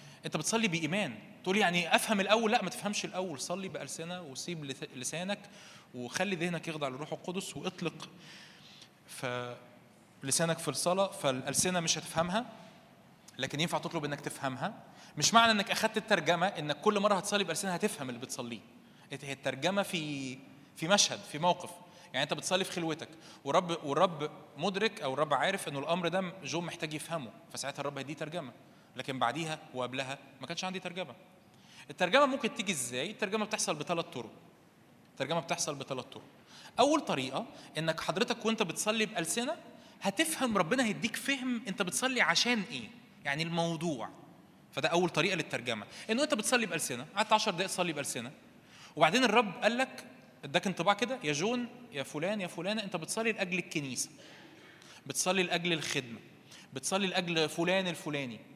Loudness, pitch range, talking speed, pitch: -32 LUFS, 150-205 Hz, 150 wpm, 175 Hz